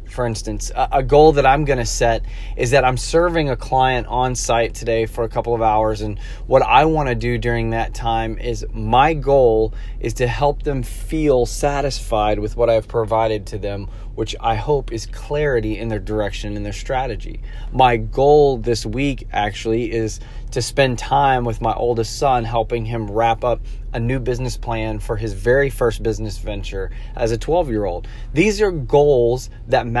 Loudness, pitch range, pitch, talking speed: -19 LUFS, 110-125 Hz, 115 Hz, 190 wpm